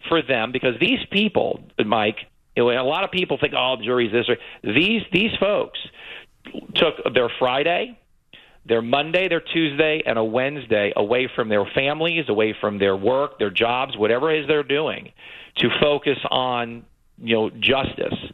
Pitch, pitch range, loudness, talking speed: 135 Hz, 120-160 Hz, -21 LUFS, 160 wpm